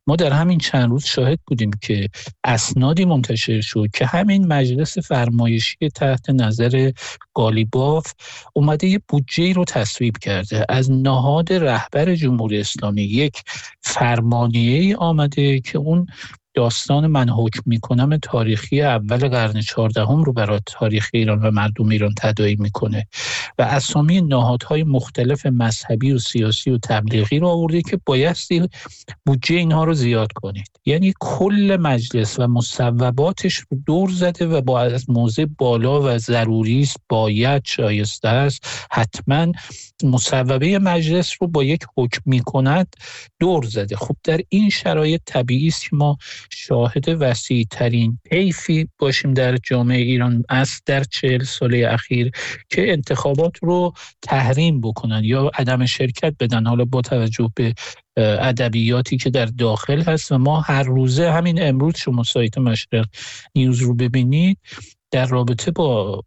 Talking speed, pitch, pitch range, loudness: 140 wpm, 130 Hz, 115-150 Hz, -18 LUFS